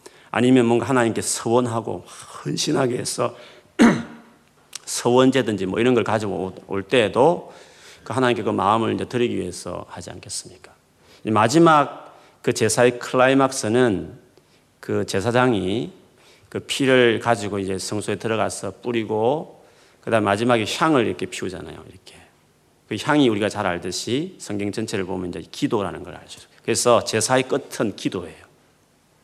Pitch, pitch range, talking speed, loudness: 115 Hz, 100-125 Hz, 315 characters per minute, -21 LUFS